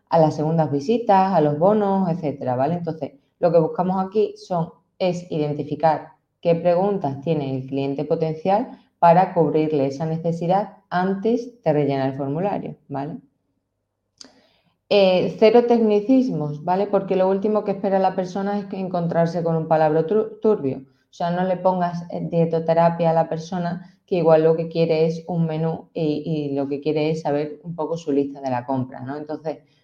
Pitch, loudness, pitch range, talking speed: 165 Hz, -21 LUFS, 150-190 Hz, 170 wpm